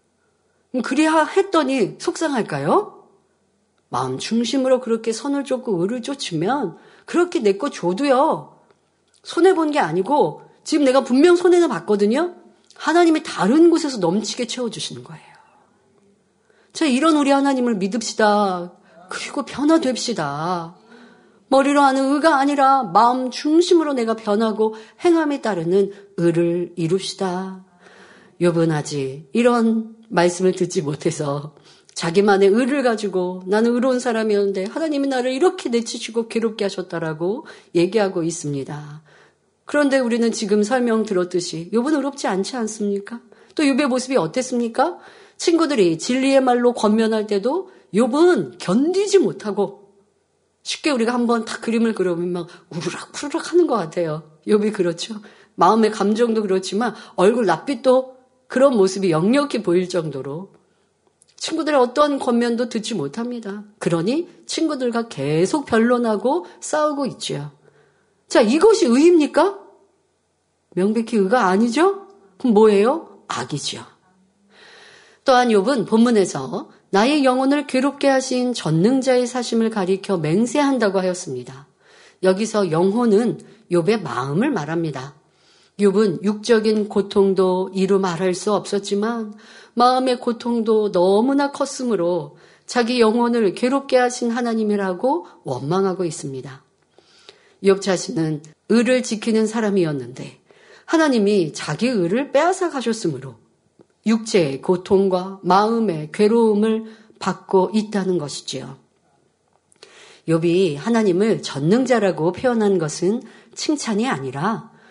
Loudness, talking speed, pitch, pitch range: -19 LUFS, 290 characters per minute, 220 Hz, 190-265 Hz